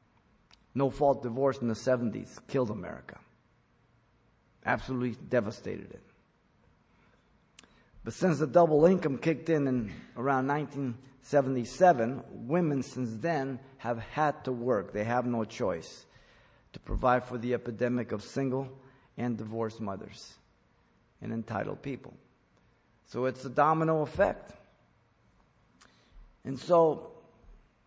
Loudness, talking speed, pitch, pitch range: -30 LUFS, 110 wpm, 130 Hz, 120-140 Hz